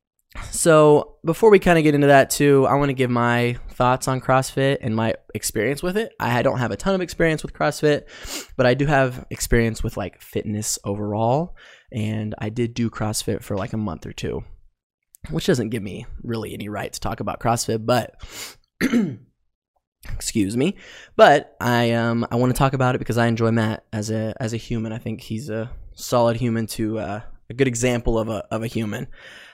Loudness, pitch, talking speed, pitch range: -21 LUFS, 115 Hz, 200 wpm, 110-135 Hz